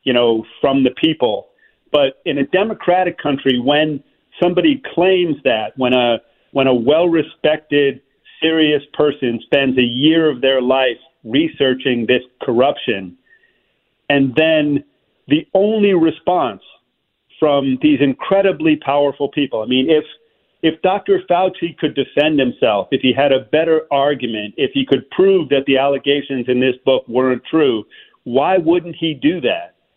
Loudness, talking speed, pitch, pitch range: -16 LUFS, 145 wpm, 145 Hz, 130-170 Hz